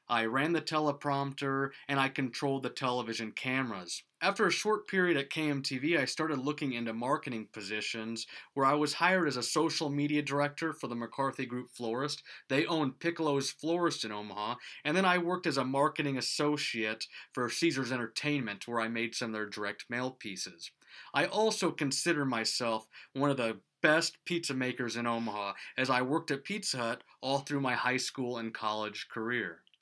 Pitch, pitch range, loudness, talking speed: 135 Hz, 120-150 Hz, -33 LUFS, 175 wpm